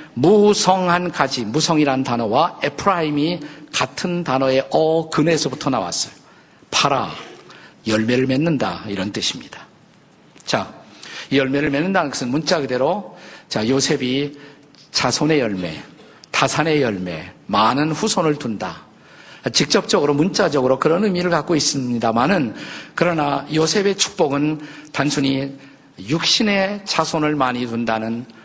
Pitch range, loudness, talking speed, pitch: 130-160 Hz, -19 LUFS, 270 characters per minute, 145 Hz